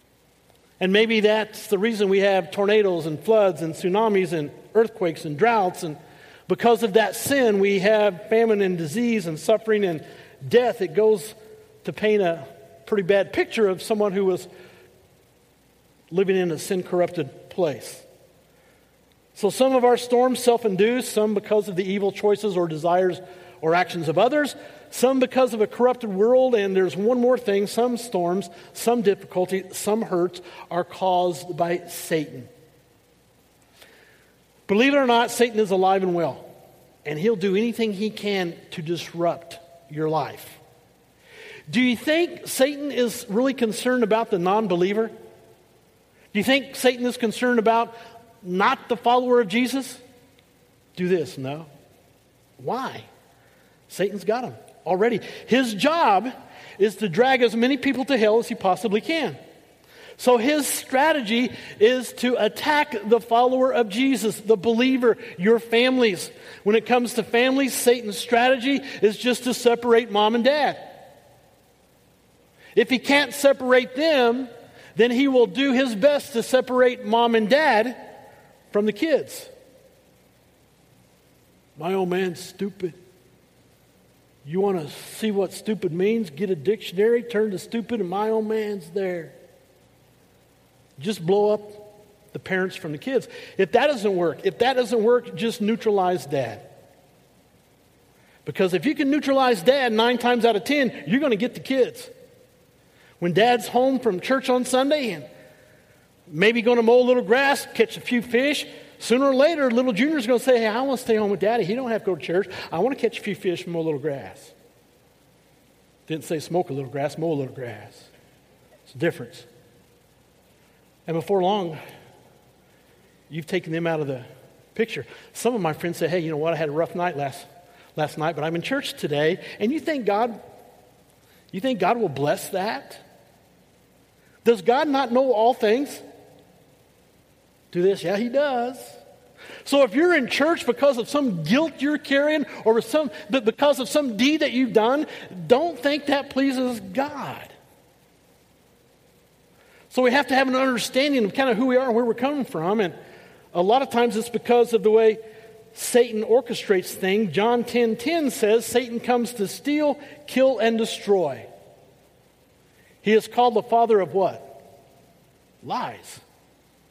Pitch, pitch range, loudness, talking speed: 220 Hz, 180-250 Hz, -22 LUFS, 160 wpm